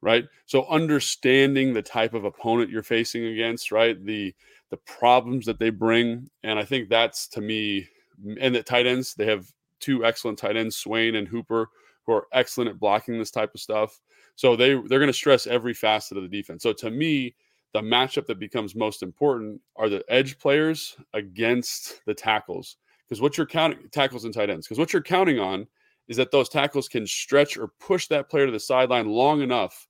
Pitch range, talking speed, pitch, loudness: 110-135 Hz, 200 wpm, 120 Hz, -24 LUFS